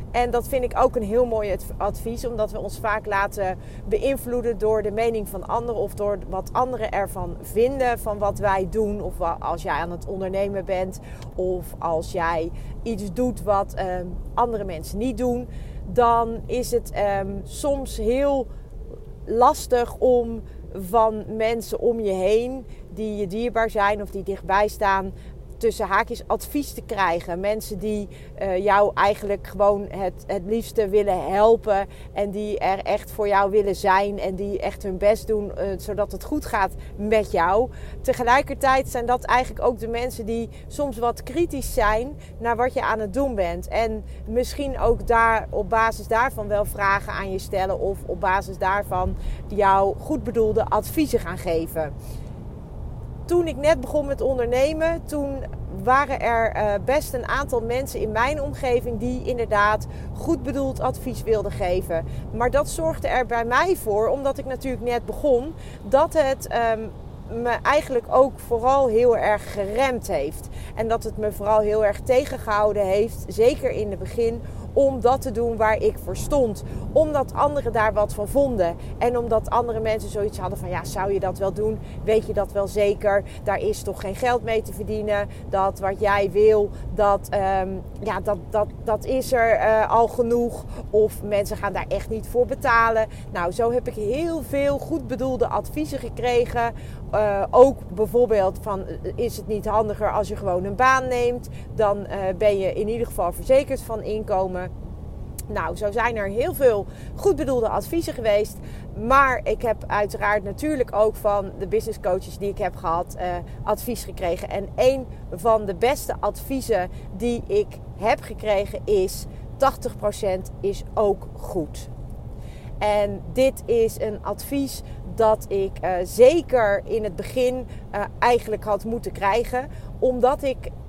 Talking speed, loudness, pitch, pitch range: 165 wpm, -23 LUFS, 220 Hz, 200-250 Hz